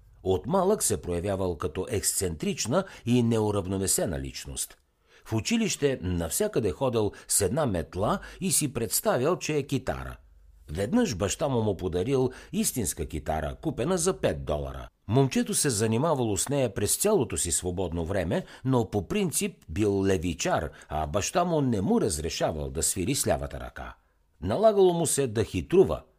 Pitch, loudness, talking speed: 105 Hz, -27 LUFS, 145 wpm